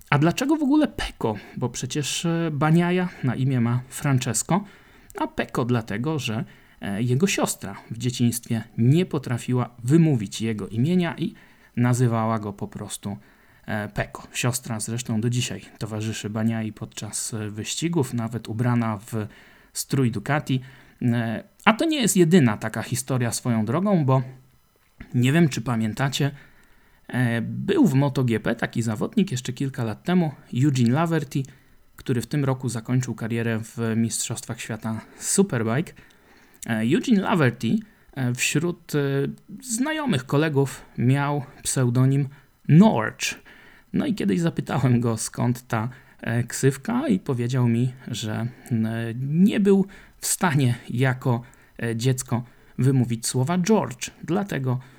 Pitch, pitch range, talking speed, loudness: 125 Hz, 115-150 Hz, 120 wpm, -24 LUFS